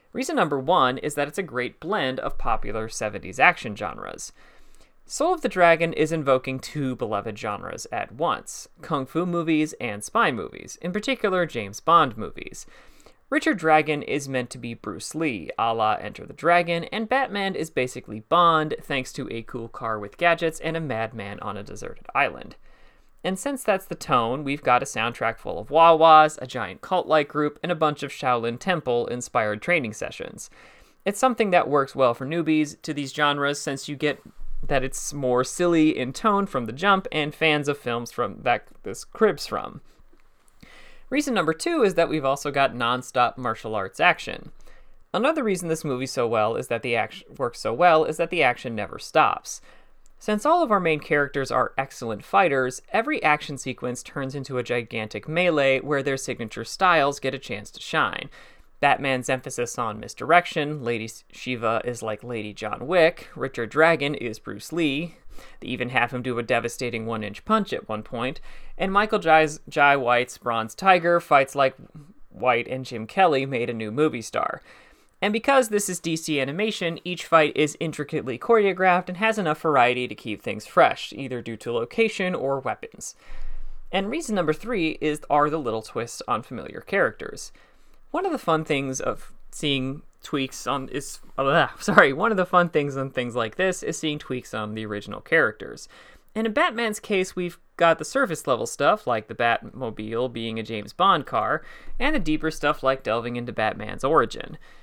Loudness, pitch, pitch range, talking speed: -24 LUFS, 145 Hz, 125-170 Hz, 185 wpm